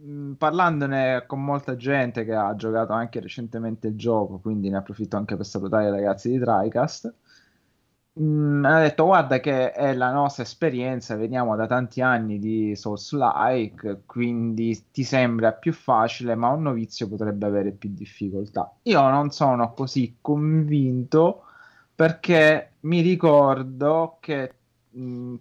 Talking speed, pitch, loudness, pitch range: 145 wpm, 125 Hz, -23 LUFS, 110-145 Hz